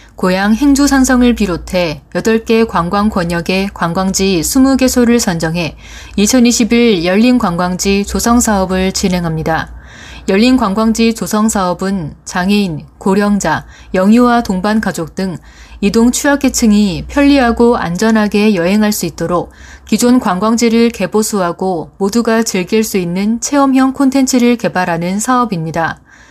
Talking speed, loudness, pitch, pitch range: 275 characters per minute, -12 LUFS, 205 Hz, 185-235 Hz